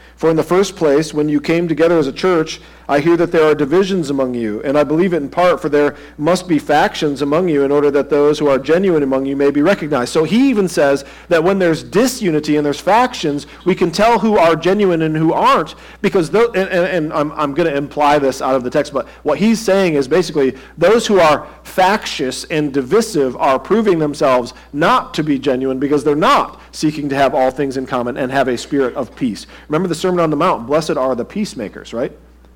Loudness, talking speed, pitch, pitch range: -15 LUFS, 230 wpm, 155 Hz, 140-180 Hz